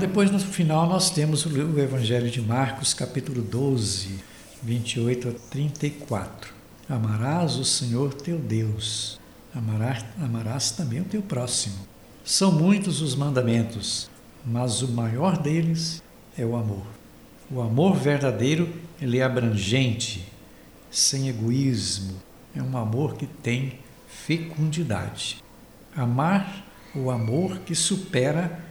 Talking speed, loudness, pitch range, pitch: 115 wpm, -25 LUFS, 115-160 Hz, 130 Hz